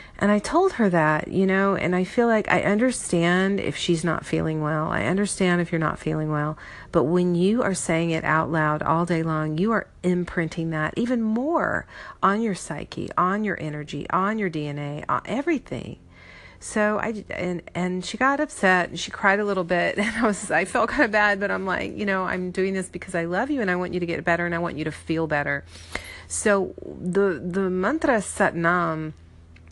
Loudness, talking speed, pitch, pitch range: -23 LUFS, 215 wpm, 180 Hz, 160-205 Hz